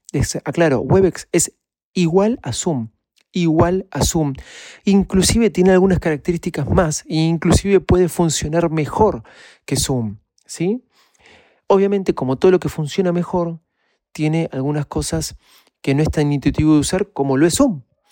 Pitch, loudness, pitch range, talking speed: 165 Hz, -18 LUFS, 150-185 Hz, 145 wpm